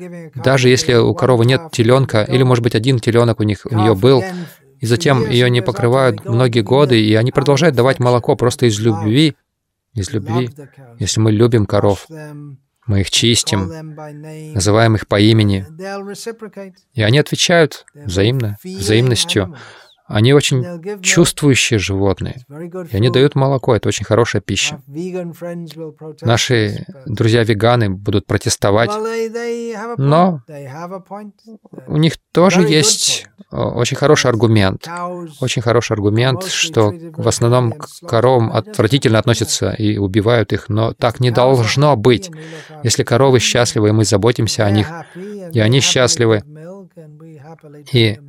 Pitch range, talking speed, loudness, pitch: 110-155 Hz, 130 wpm, -14 LUFS, 125 Hz